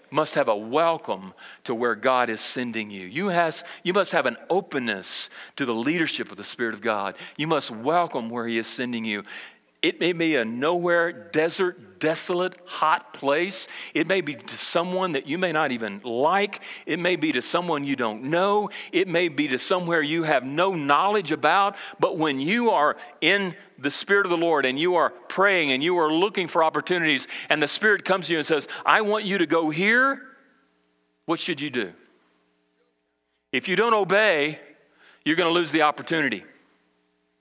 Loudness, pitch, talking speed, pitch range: -23 LUFS, 165 Hz, 190 wpm, 125-185 Hz